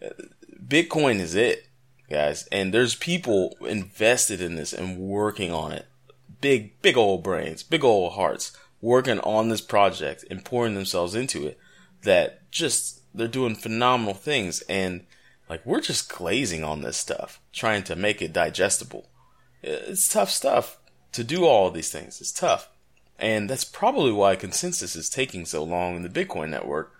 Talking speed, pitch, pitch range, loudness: 160 wpm, 105 Hz, 90-130 Hz, -24 LUFS